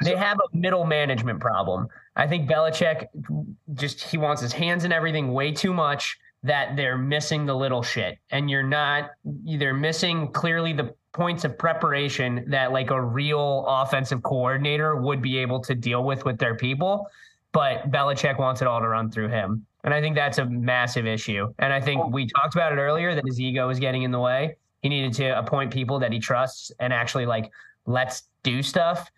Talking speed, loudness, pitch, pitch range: 195 wpm, -24 LUFS, 135 Hz, 125-155 Hz